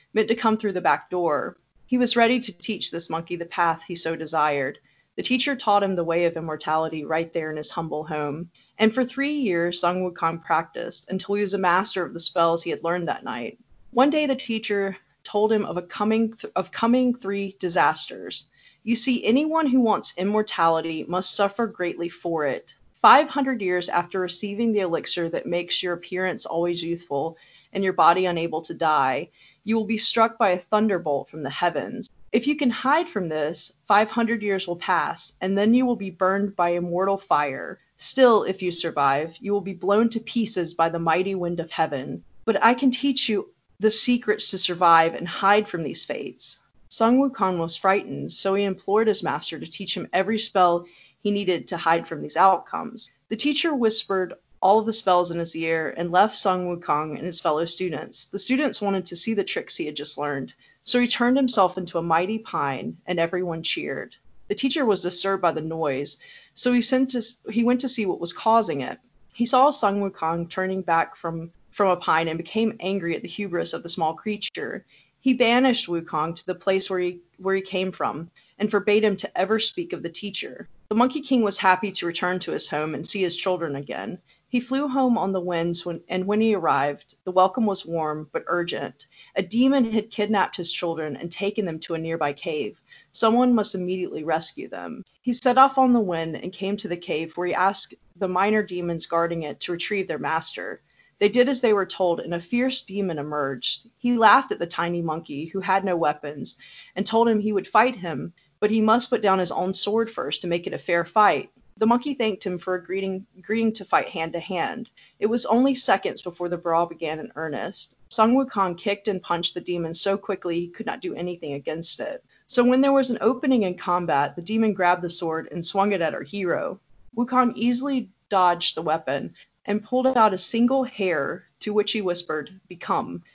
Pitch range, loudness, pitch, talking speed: 170-220 Hz, -23 LUFS, 190 Hz, 210 wpm